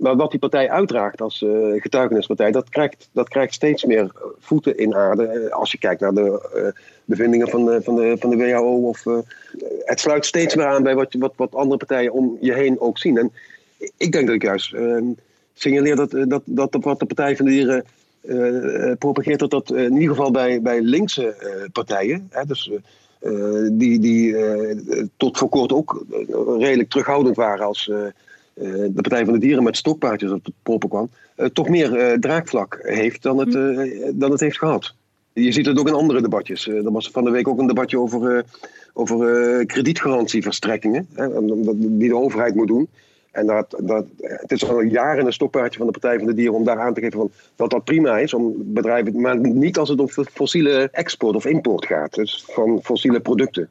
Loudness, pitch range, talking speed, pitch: -19 LUFS, 115-140 Hz, 200 wpm, 125 Hz